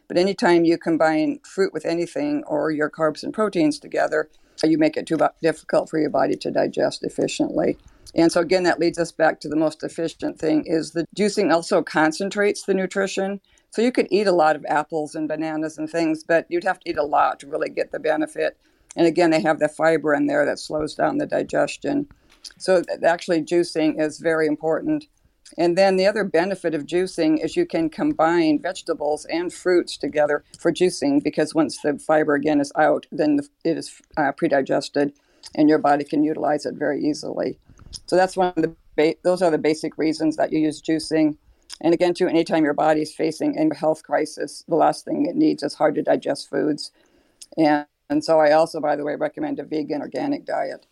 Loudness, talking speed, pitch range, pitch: -22 LUFS, 205 wpm, 155-190 Hz, 165 Hz